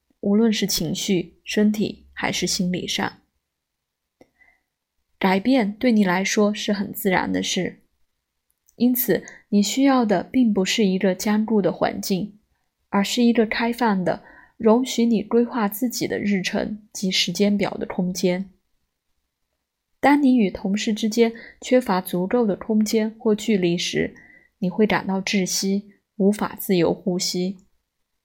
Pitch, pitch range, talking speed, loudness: 200 Hz, 180-225 Hz, 200 characters per minute, -21 LUFS